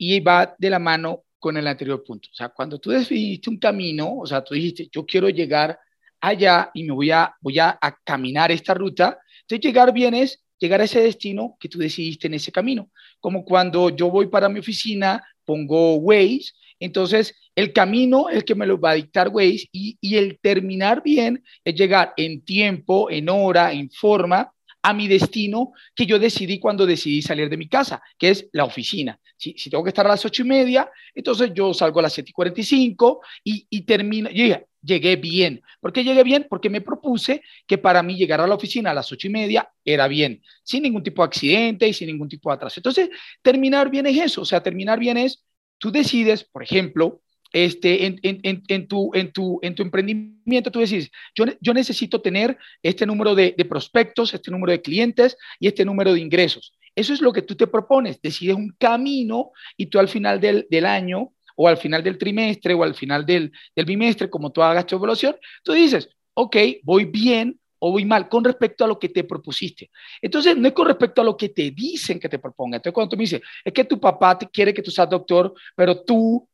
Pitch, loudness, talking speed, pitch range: 195 Hz, -19 LUFS, 220 wpm, 175-230 Hz